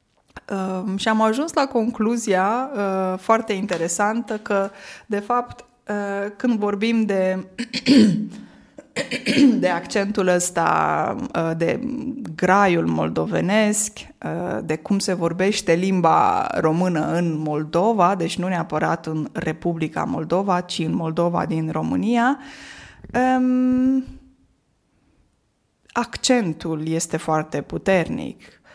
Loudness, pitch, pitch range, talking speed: -21 LUFS, 200 Hz, 170-235 Hz, 100 wpm